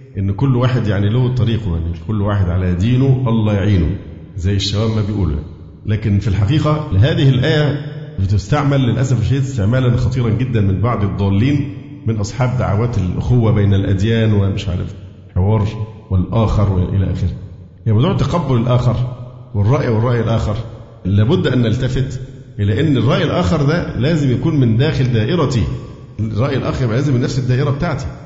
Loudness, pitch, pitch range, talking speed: -16 LUFS, 115 Hz, 100-130 Hz, 150 wpm